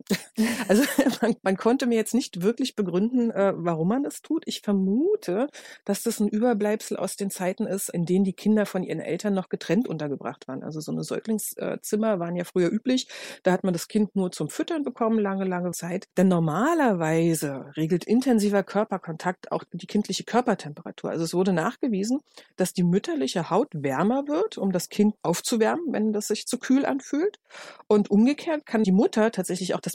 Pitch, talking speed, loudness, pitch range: 205 Hz, 180 wpm, -25 LUFS, 180-235 Hz